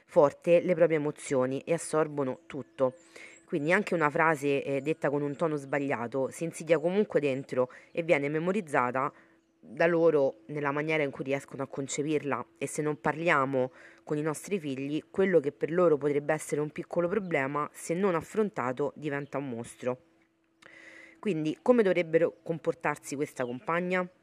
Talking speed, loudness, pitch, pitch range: 155 wpm, -29 LUFS, 150 Hz, 140-170 Hz